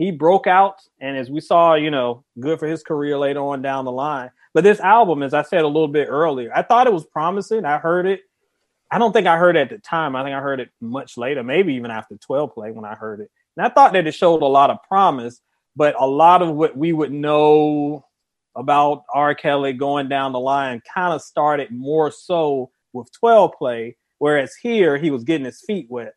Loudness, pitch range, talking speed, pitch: -18 LUFS, 135-170 Hz, 235 wpm, 150 Hz